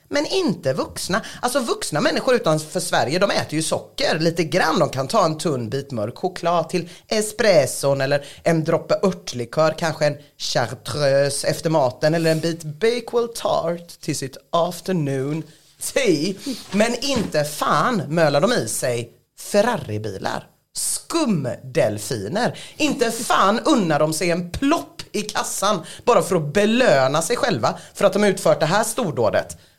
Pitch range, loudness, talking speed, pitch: 145-205 Hz, -21 LUFS, 145 wpm, 165 Hz